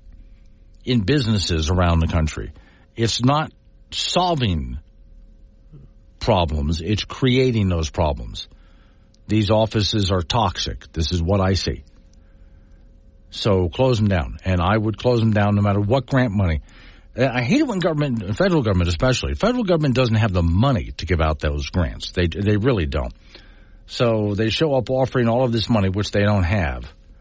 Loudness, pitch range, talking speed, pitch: -20 LUFS, 85-115 Hz, 165 wpm, 100 Hz